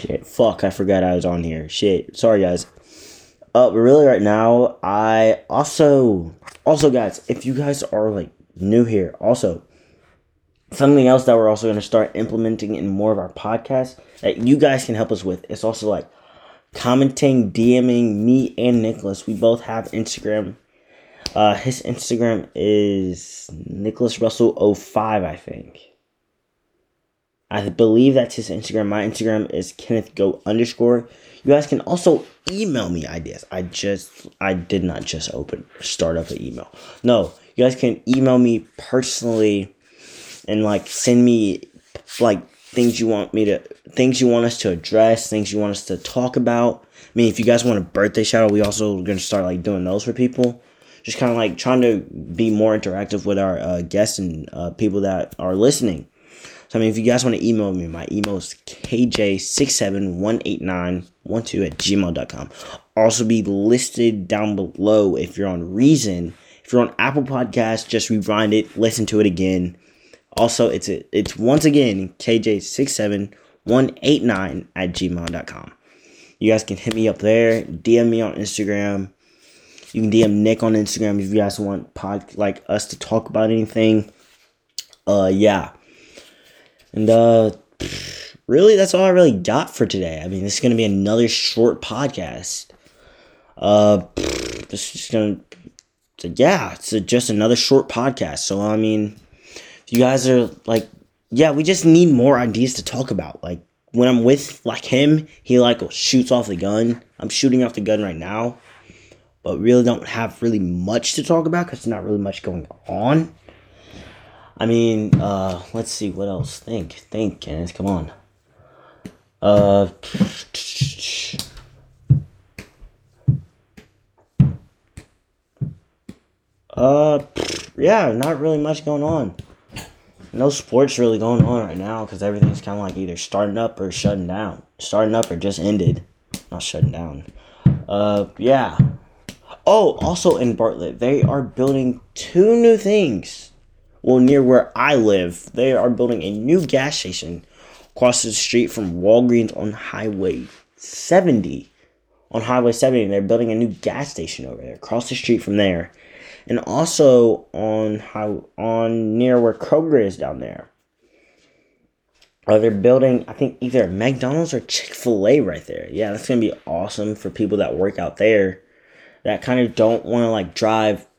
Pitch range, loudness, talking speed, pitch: 100-120 Hz, -18 LUFS, 165 wpm, 110 Hz